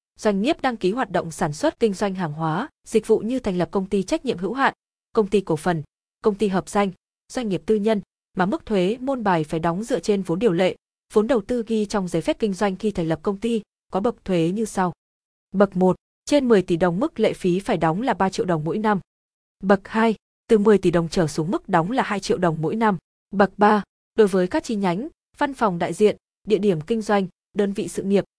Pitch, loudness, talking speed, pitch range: 205 Hz, -22 LUFS, 250 wpm, 180-225 Hz